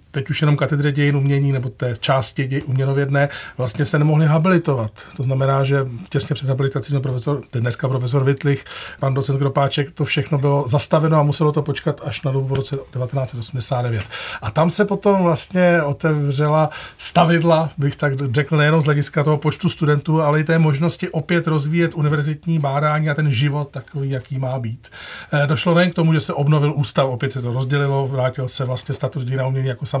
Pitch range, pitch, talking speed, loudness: 135-155 Hz, 145 Hz, 190 wpm, -19 LUFS